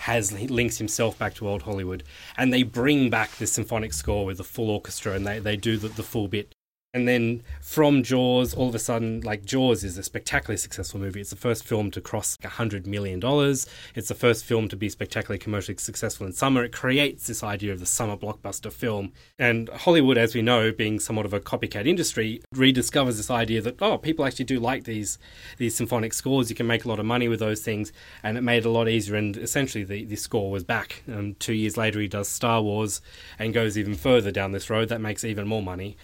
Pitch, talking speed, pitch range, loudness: 110 Hz, 230 wpm, 105-120 Hz, -25 LUFS